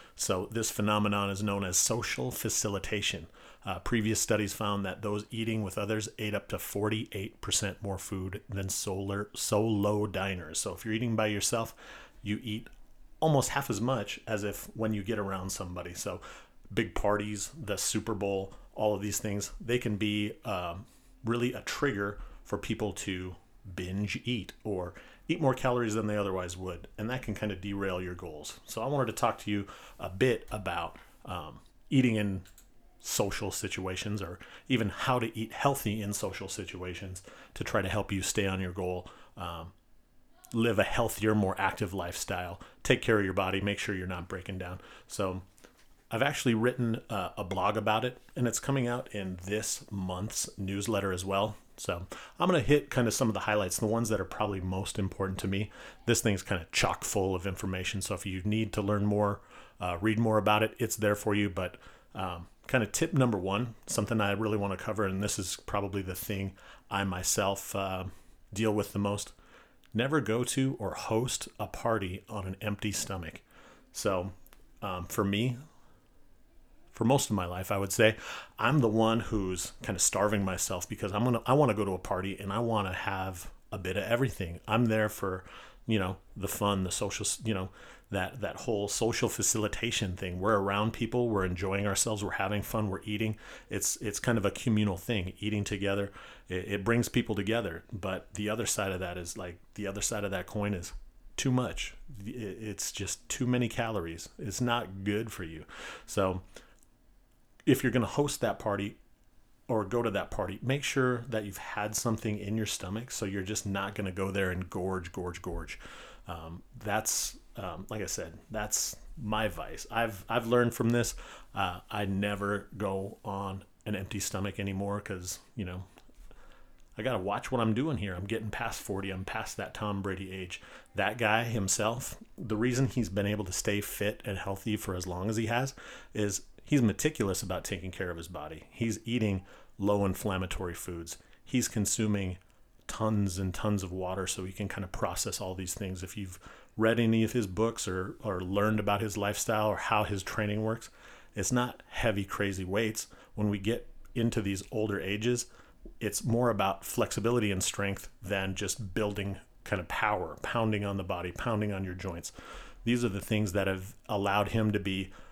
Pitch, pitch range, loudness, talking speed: 105 Hz, 95-110 Hz, -32 LUFS, 190 wpm